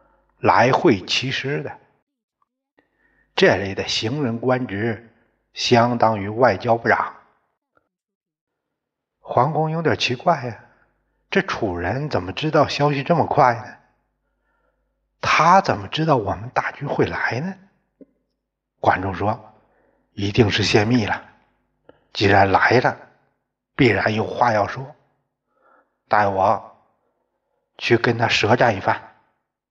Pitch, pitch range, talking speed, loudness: 120 Hz, 110-155 Hz, 160 characters per minute, -19 LUFS